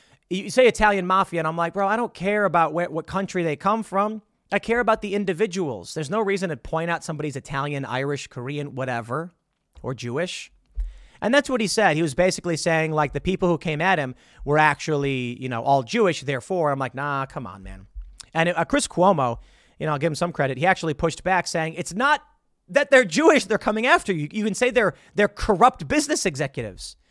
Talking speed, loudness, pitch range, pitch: 215 wpm, -22 LUFS, 145-200 Hz, 170 Hz